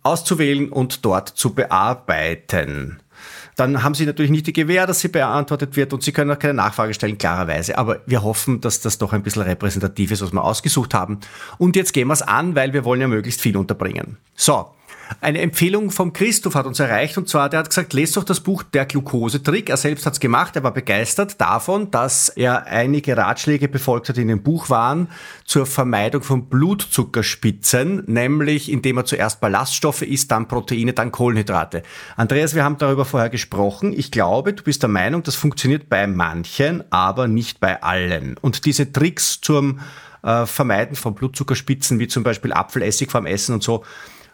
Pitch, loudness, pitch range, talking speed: 130 Hz, -19 LUFS, 115-150 Hz, 190 wpm